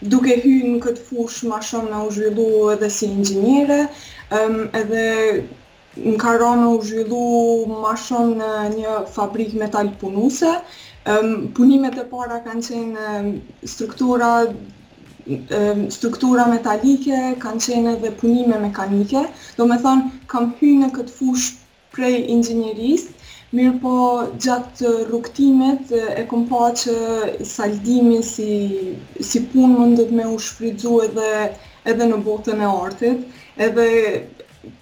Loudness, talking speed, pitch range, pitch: -18 LUFS, 130 wpm, 220-245 Hz, 235 Hz